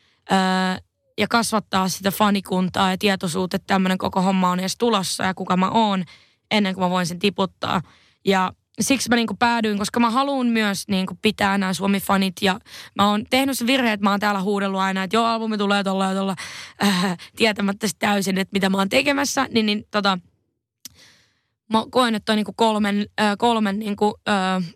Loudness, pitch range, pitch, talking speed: -21 LUFS, 190-220 Hz, 200 Hz, 185 wpm